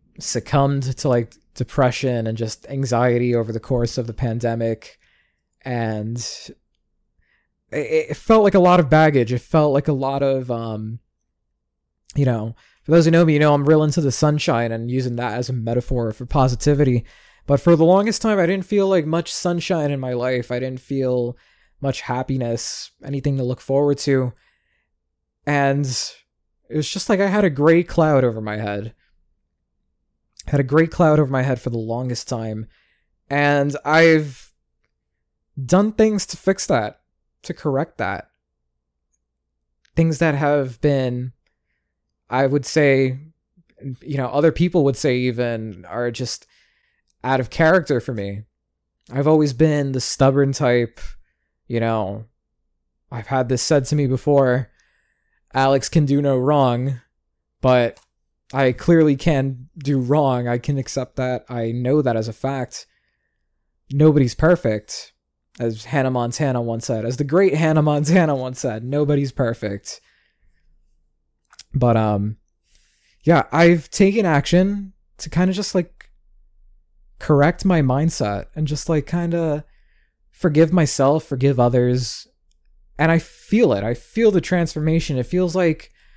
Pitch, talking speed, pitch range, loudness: 130 Hz, 150 wpm, 115-150 Hz, -19 LUFS